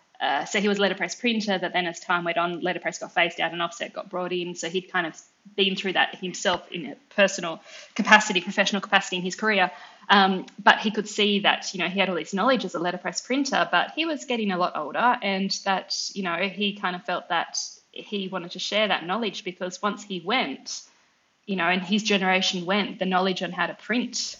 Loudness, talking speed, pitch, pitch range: -24 LUFS, 230 wpm, 190 Hz, 180-210 Hz